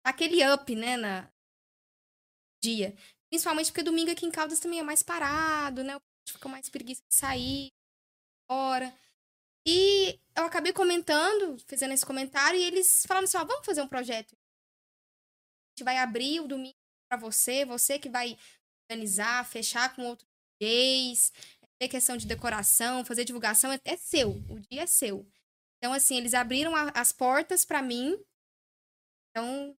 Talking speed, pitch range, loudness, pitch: 160 wpm, 245-320 Hz, -27 LUFS, 270 Hz